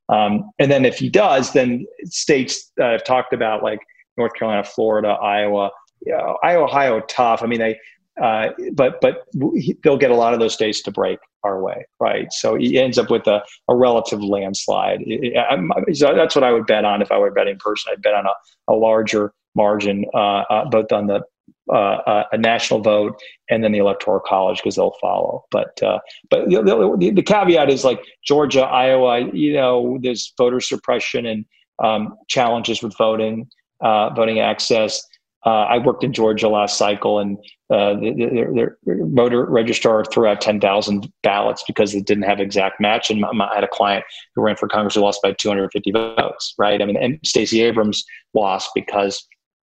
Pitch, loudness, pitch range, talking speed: 110 Hz, -18 LUFS, 105-125 Hz, 190 wpm